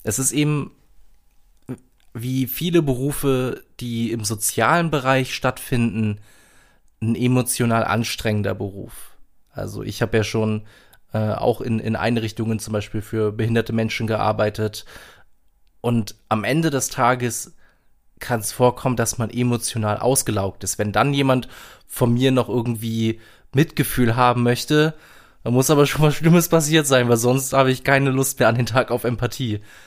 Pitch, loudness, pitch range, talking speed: 120 Hz, -20 LUFS, 110-130 Hz, 150 wpm